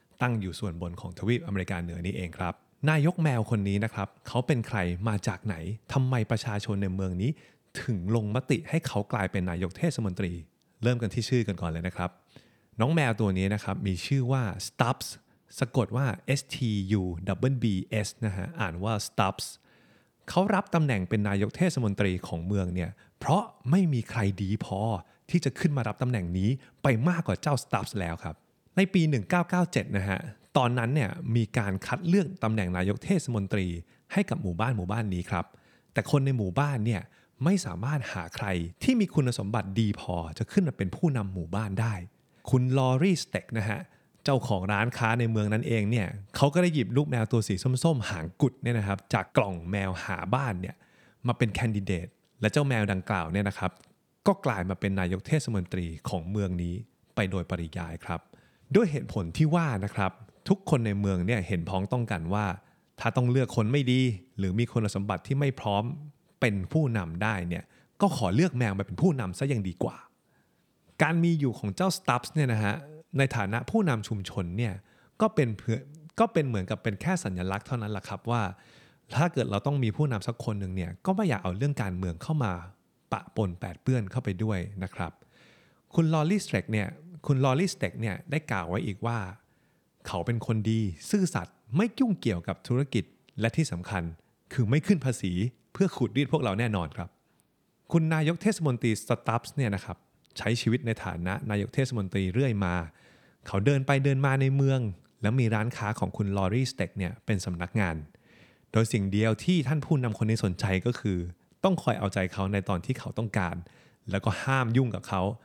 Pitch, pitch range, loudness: 110 Hz, 95-135 Hz, -29 LUFS